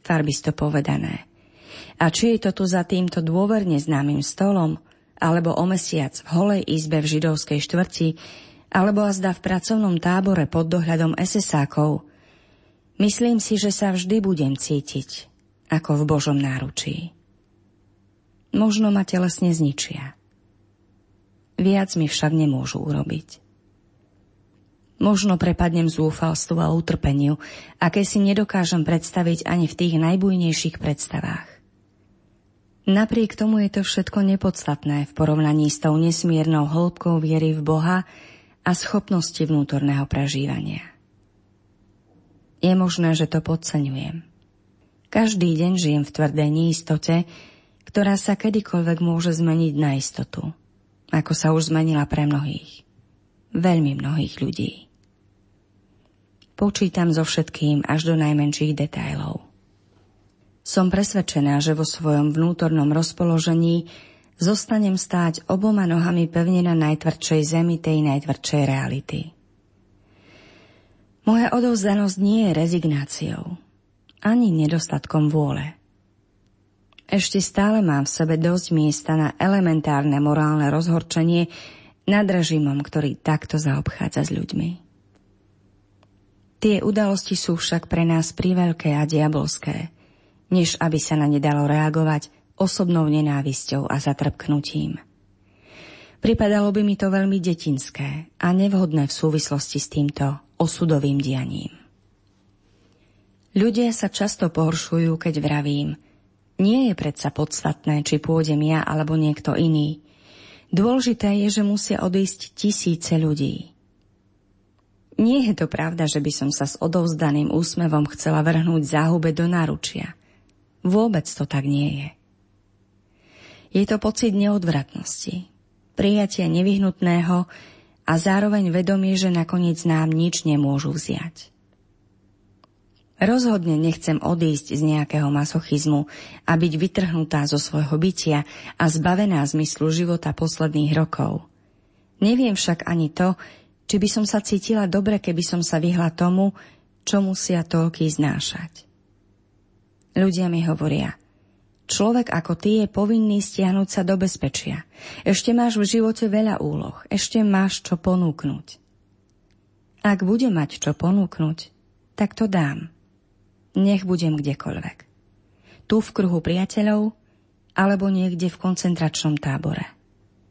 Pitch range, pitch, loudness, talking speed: 140-180 Hz, 160 Hz, -21 LUFS, 115 wpm